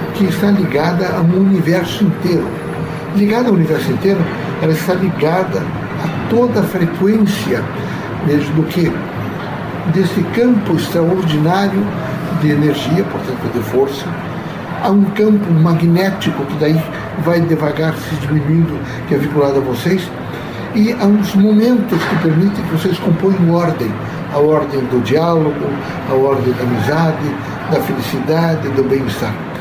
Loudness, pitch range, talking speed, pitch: -15 LUFS, 150-190 Hz, 130 wpm, 165 Hz